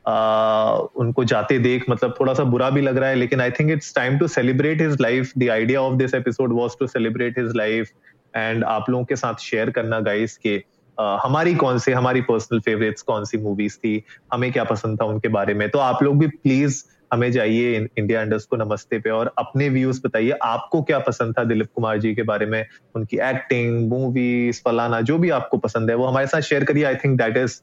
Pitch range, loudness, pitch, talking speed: 110-130 Hz, -20 LUFS, 120 Hz, 175 wpm